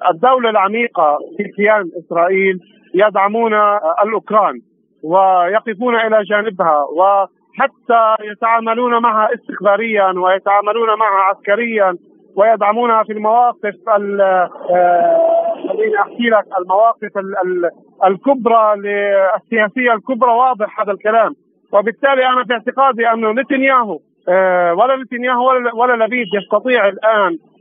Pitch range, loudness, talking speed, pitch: 195-240 Hz, -14 LUFS, 90 wpm, 215 Hz